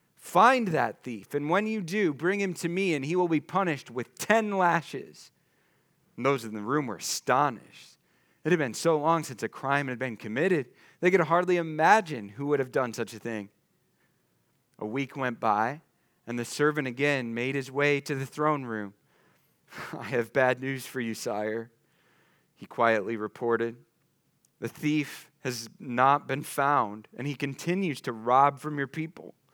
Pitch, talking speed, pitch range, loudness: 140 Hz, 175 wpm, 120-160 Hz, -28 LUFS